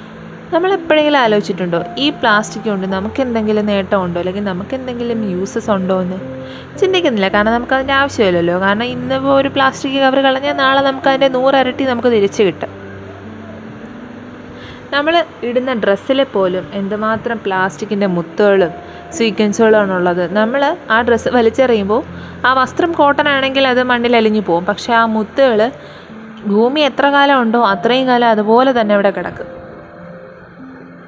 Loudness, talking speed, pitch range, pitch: -14 LUFS, 125 wpm, 200-265 Hz, 230 Hz